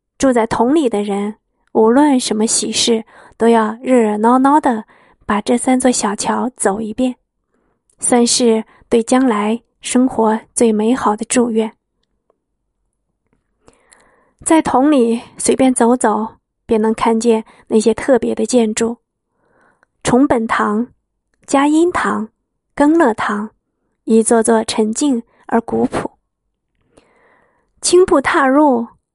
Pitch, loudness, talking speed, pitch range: 235 Hz, -15 LUFS, 165 characters per minute, 220-260 Hz